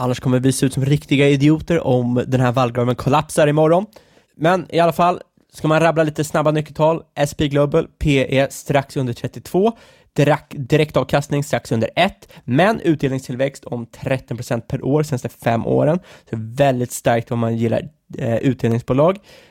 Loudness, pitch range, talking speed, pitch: -18 LUFS, 125-155 Hz, 165 wpm, 140 Hz